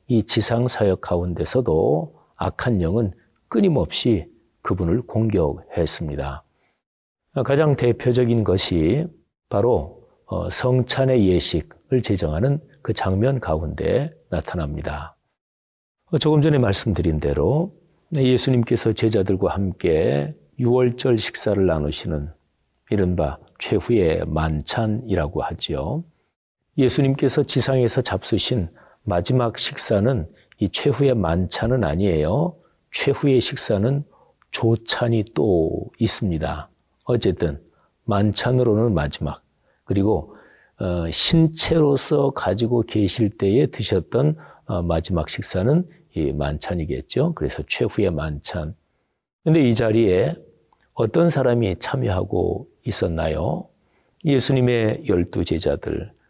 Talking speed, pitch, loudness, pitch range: 235 characters per minute, 110 Hz, -21 LUFS, 85-130 Hz